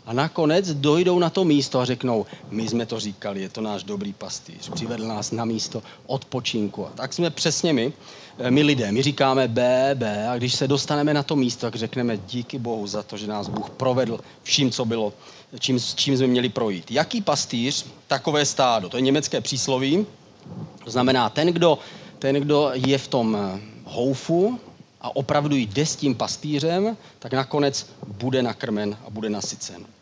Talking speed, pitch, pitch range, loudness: 180 wpm, 130 Hz, 115-145 Hz, -23 LUFS